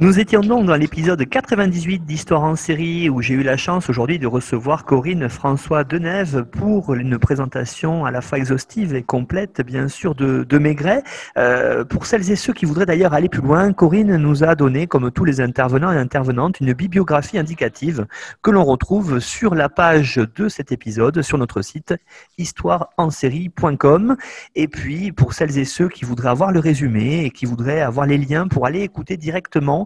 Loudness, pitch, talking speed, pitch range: -18 LUFS, 155 Hz, 185 wpm, 135-180 Hz